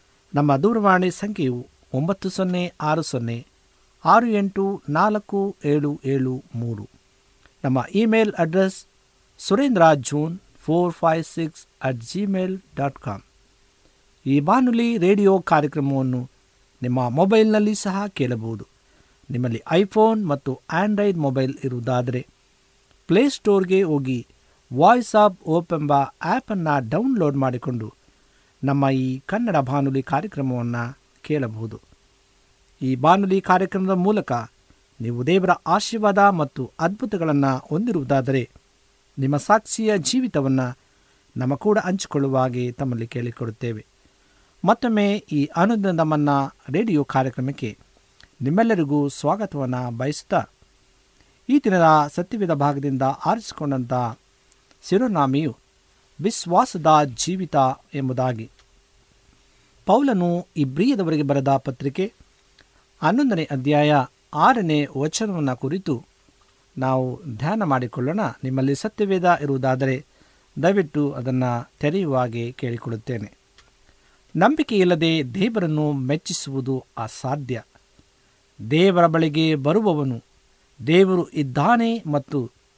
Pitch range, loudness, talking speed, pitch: 130-190 Hz, -21 LUFS, 85 wpm, 145 Hz